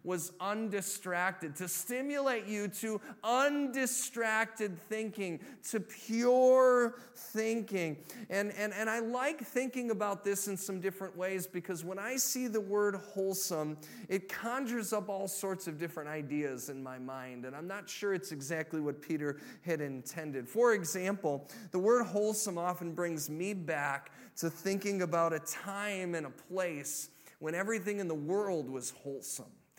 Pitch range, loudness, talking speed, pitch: 165-220 Hz, -35 LUFS, 150 wpm, 195 Hz